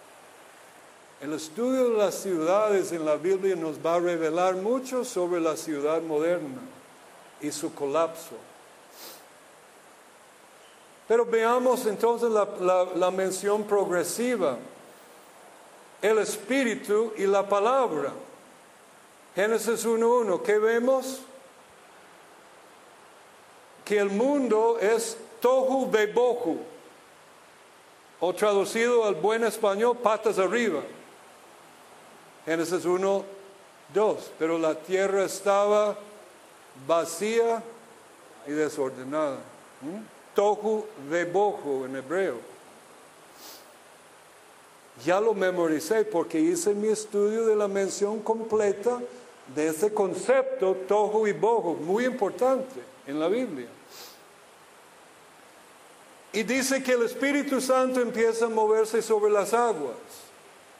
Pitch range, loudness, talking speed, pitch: 180-235 Hz, -26 LUFS, 100 wpm, 210 Hz